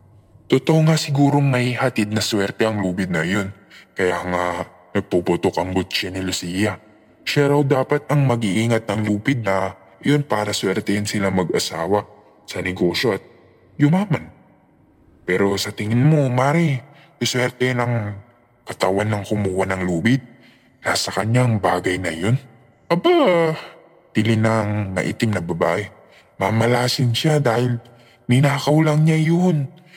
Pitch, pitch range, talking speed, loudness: 115 Hz, 100-135 Hz, 135 wpm, -20 LUFS